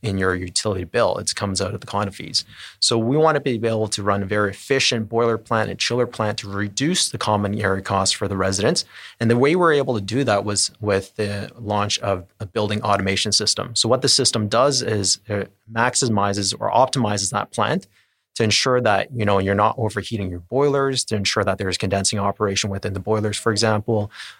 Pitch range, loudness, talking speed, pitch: 100-115 Hz, -20 LUFS, 215 wpm, 105 Hz